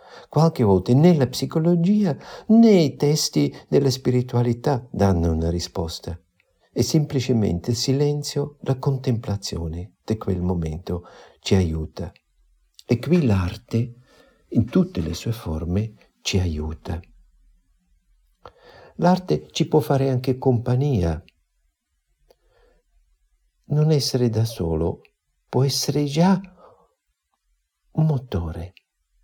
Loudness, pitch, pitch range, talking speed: -22 LUFS, 115 Hz, 85-140 Hz, 100 wpm